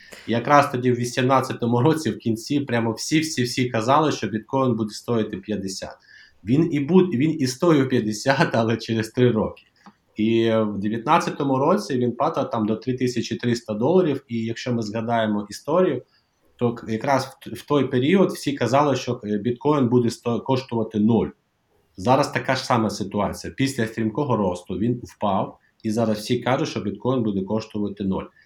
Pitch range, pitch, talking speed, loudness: 110-135 Hz, 120 Hz, 160 wpm, -22 LUFS